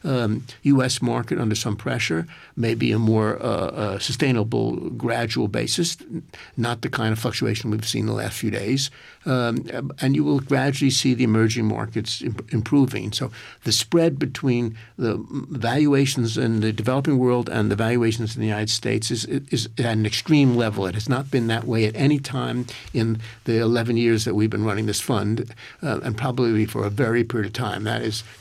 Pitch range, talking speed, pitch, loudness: 110-130 Hz, 190 wpm, 115 Hz, -22 LUFS